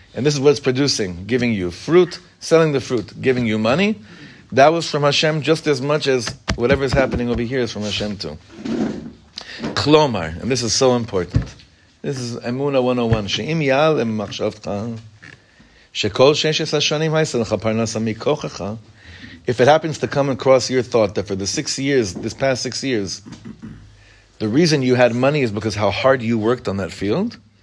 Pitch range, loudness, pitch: 110-145 Hz, -18 LUFS, 125 Hz